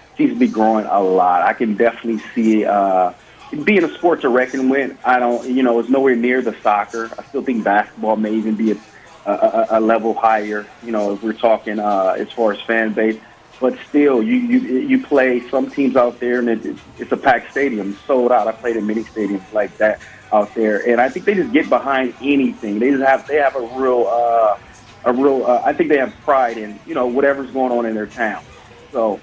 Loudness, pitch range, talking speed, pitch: -17 LUFS, 110-130 Hz, 230 wpm, 120 Hz